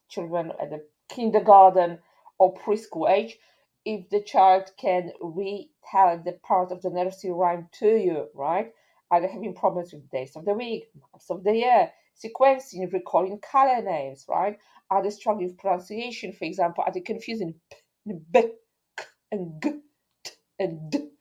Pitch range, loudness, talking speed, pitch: 180-220 Hz, -24 LUFS, 160 wpm, 190 Hz